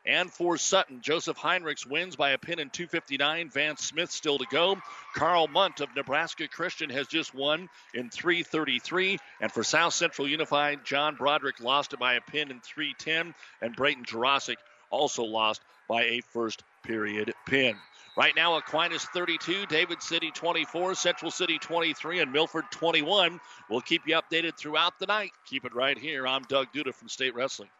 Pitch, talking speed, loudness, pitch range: 155 Hz, 175 wpm, -28 LUFS, 135-170 Hz